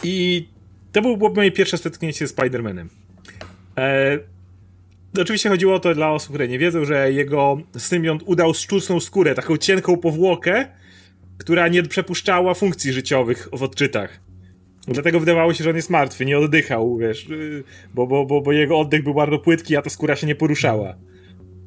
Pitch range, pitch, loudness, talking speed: 110-170 Hz, 145 Hz, -19 LUFS, 165 wpm